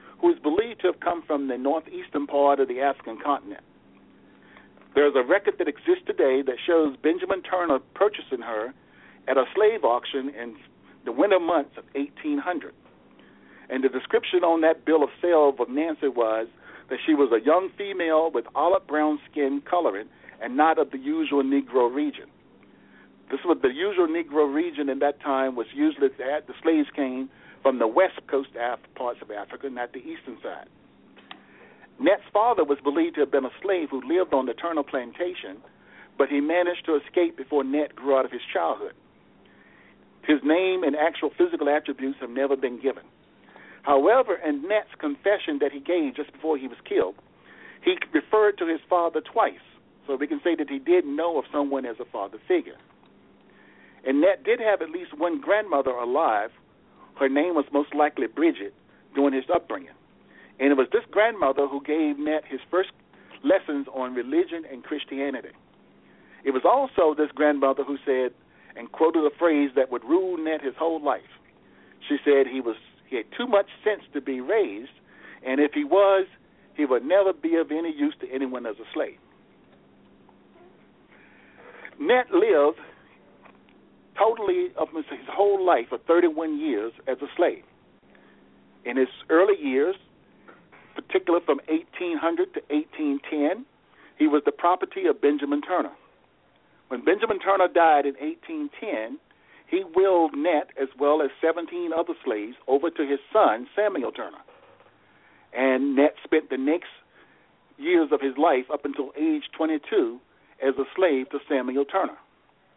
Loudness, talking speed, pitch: -24 LUFS, 165 wpm, 160 Hz